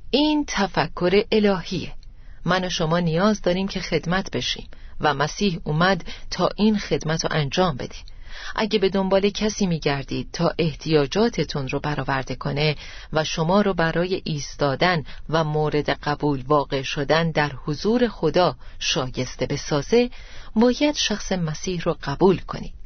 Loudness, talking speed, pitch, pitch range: -22 LUFS, 135 wpm, 165 Hz, 145-195 Hz